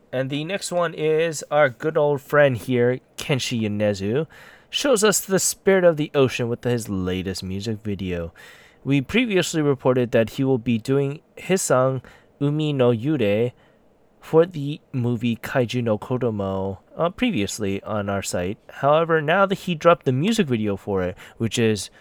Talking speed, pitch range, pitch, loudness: 165 wpm, 110-155 Hz, 130 Hz, -22 LUFS